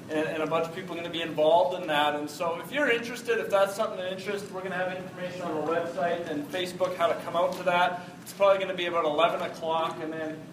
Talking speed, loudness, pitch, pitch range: 275 wpm, -28 LUFS, 175 Hz, 165-185 Hz